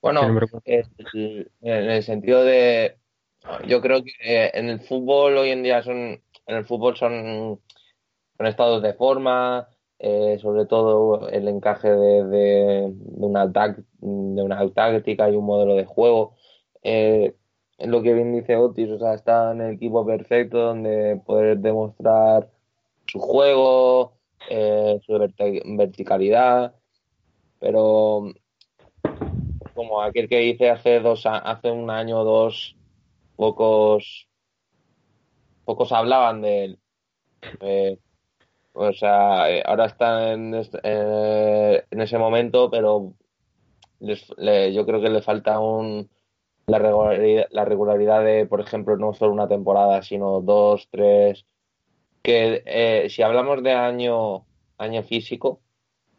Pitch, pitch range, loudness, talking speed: 110 Hz, 105-120 Hz, -20 LUFS, 130 wpm